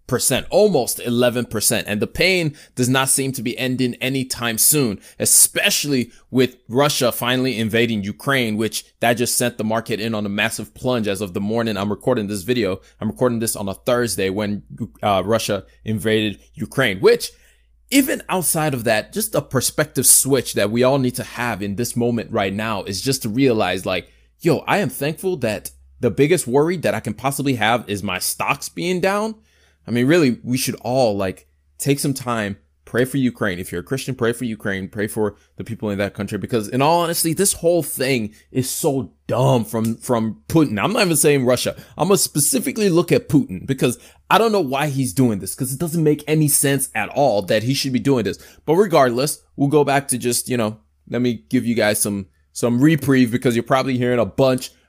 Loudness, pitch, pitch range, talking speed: -19 LUFS, 120 Hz, 105-140 Hz, 210 wpm